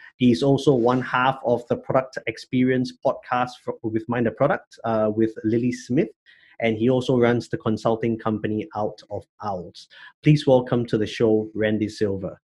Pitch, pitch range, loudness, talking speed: 120 Hz, 110-125 Hz, -23 LUFS, 170 wpm